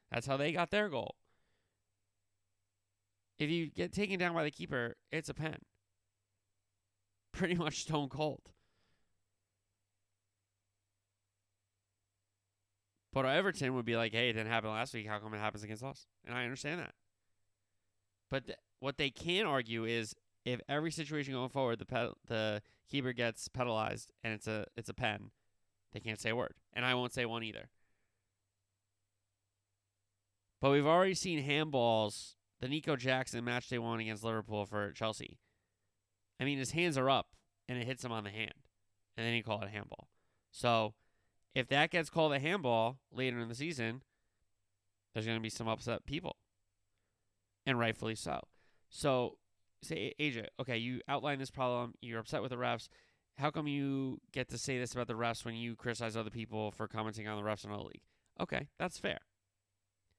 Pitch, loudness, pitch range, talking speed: 110 Hz, -37 LUFS, 100-130 Hz, 170 wpm